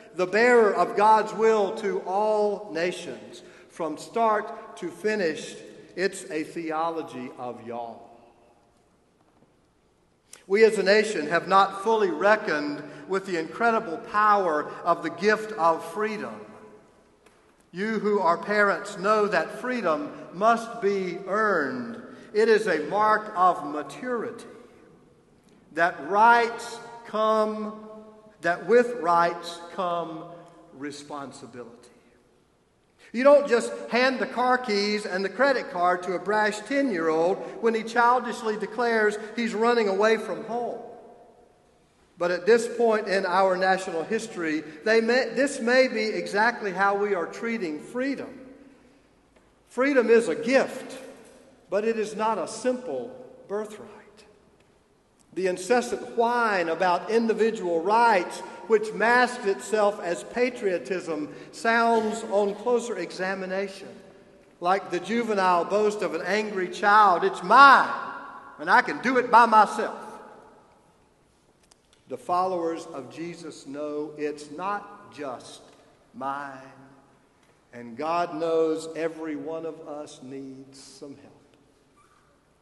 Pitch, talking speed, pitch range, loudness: 205 Hz, 120 wpm, 170-230 Hz, -24 LUFS